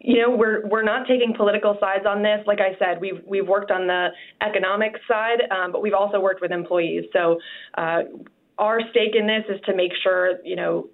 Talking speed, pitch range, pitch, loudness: 215 wpm, 185-220 Hz, 205 Hz, -21 LUFS